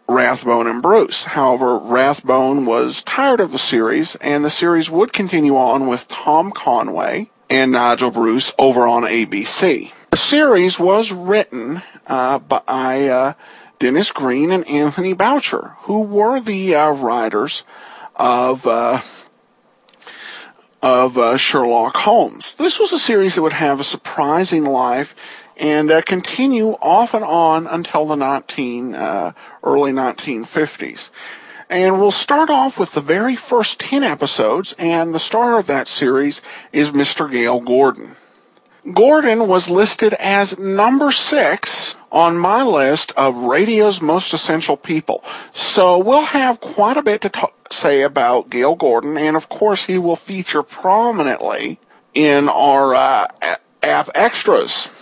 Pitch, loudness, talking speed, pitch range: 165 Hz, -15 LUFS, 140 wpm, 140-210 Hz